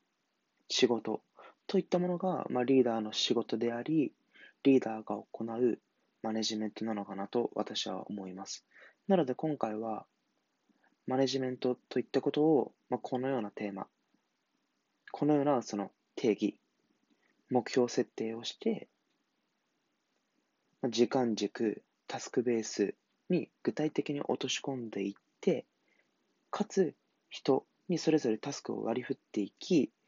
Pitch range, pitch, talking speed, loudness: 110-145 Hz, 125 Hz, 255 characters per minute, -33 LUFS